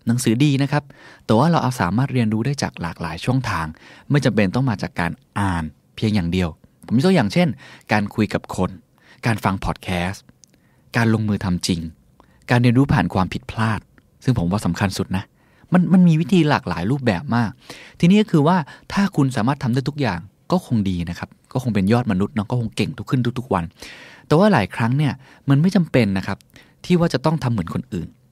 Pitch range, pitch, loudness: 95-140 Hz, 115 Hz, -20 LUFS